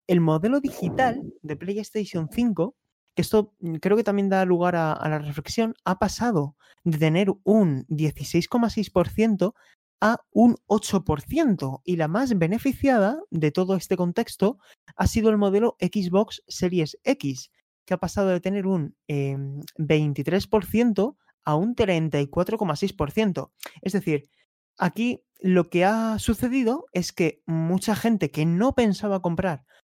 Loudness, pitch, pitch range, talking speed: -24 LUFS, 190 Hz, 160-215 Hz, 135 wpm